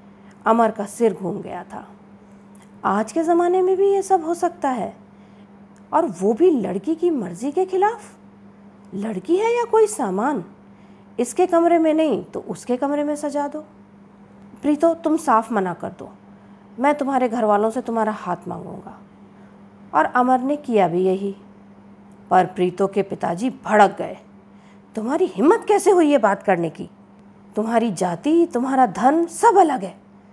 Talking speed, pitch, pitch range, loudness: 160 wpm, 220 Hz, 200-300 Hz, -20 LUFS